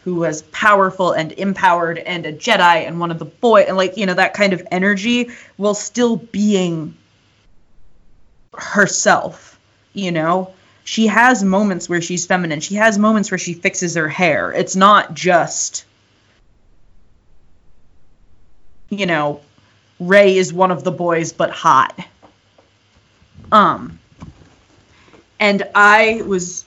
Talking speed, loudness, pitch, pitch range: 130 wpm, -15 LUFS, 180 Hz, 150-200 Hz